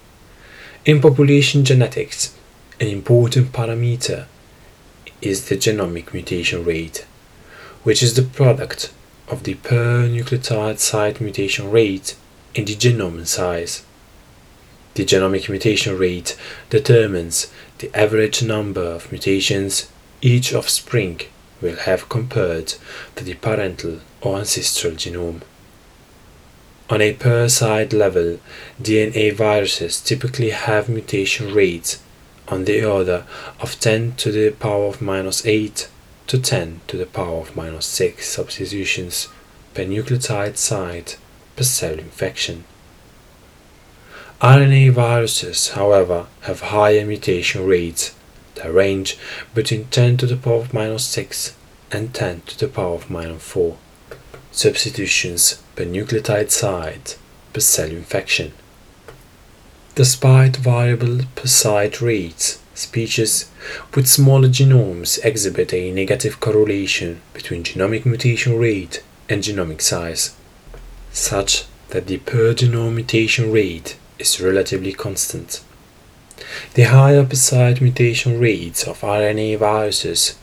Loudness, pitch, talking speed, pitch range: -17 LUFS, 110 Hz, 110 wpm, 95-120 Hz